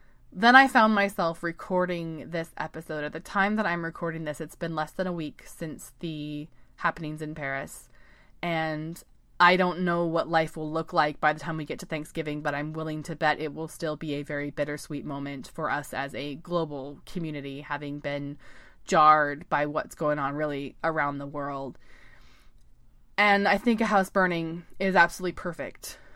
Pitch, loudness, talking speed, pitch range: 155 Hz, -27 LUFS, 185 wpm, 145-170 Hz